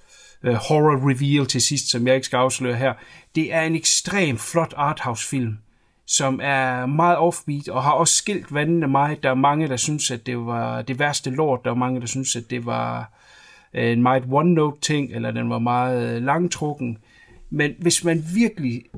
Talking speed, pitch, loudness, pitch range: 185 wpm, 135 Hz, -21 LUFS, 125-155 Hz